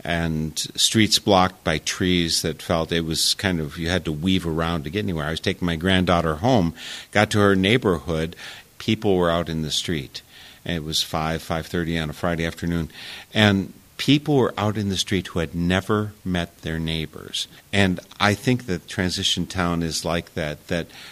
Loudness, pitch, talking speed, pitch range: -22 LUFS, 85 Hz, 195 wpm, 80-100 Hz